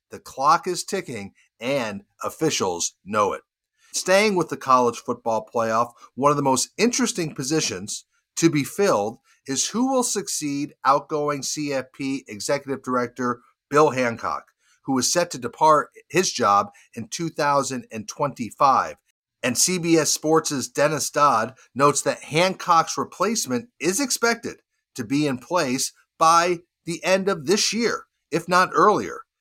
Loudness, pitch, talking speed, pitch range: -22 LUFS, 155 Hz, 135 wpm, 130-185 Hz